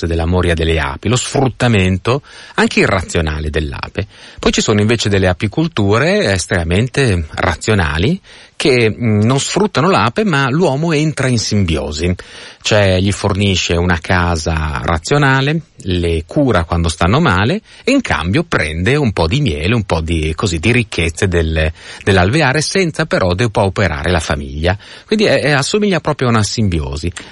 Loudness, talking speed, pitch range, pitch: -14 LUFS, 145 wpm, 85-135 Hz, 100 Hz